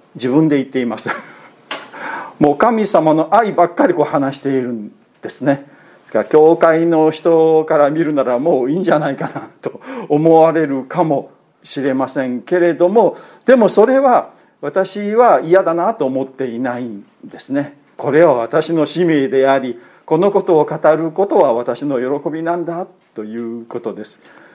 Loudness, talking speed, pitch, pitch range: -14 LUFS, 310 characters per minute, 160 Hz, 135-180 Hz